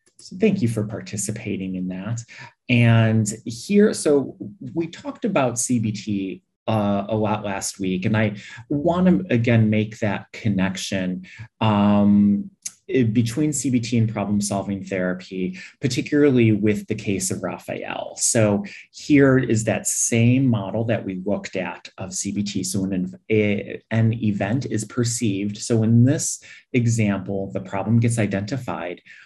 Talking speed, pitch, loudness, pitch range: 135 wpm, 110 Hz, -21 LUFS, 100-120 Hz